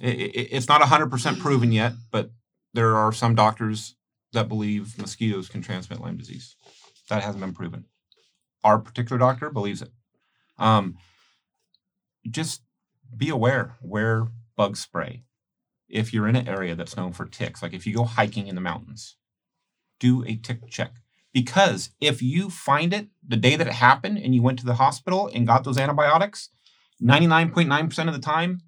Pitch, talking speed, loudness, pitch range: 120 Hz, 165 wpm, -23 LUFS, 110-140 Hz